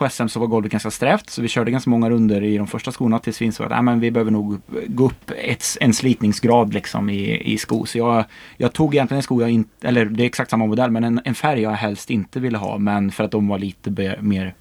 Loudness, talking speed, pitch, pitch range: -20 LUFS, 265 wpm, 115 Hz, 105-120 Hz